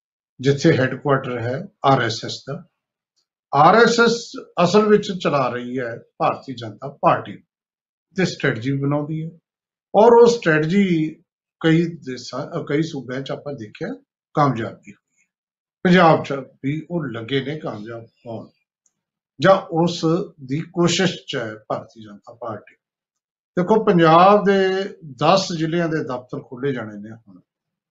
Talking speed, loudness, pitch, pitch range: 125 wpm, -19 LUFS, 155 Hz, 135-180 Hz